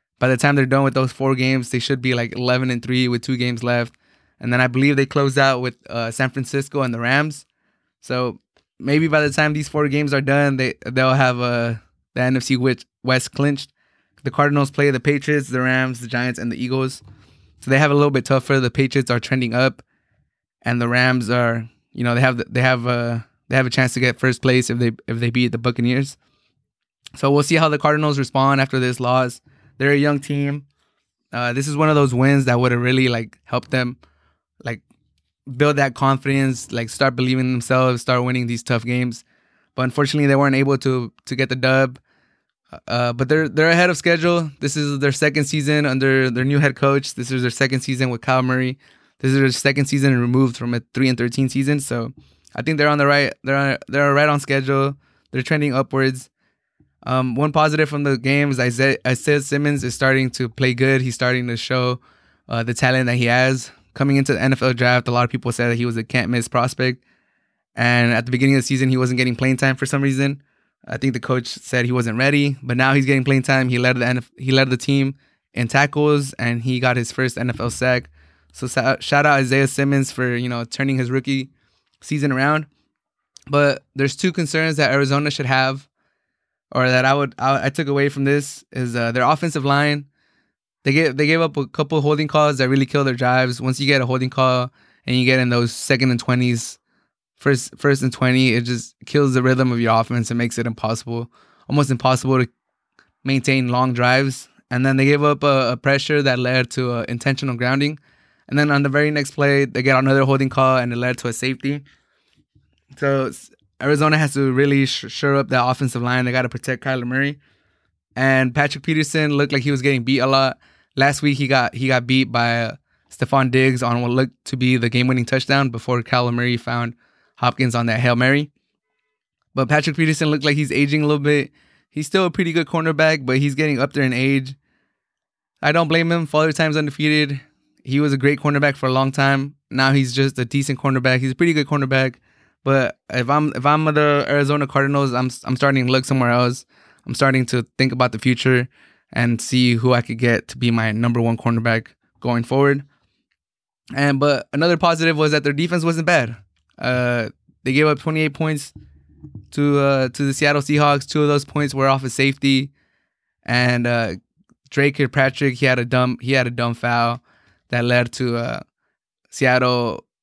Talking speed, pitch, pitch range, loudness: 215 wpm, 130 Hz, 125-140 Hz, -18 LUFS